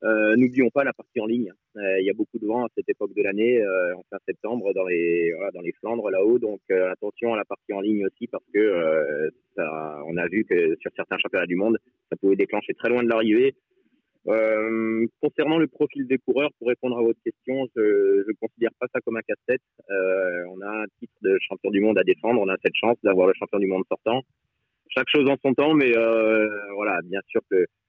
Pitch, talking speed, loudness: 125 Hz, 235 wpm, -23 LUFS